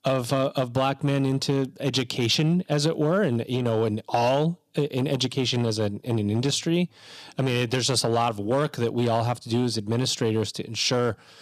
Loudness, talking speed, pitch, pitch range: -25 LUFS, 210 wpm, 130 Hz, 115-140 Hz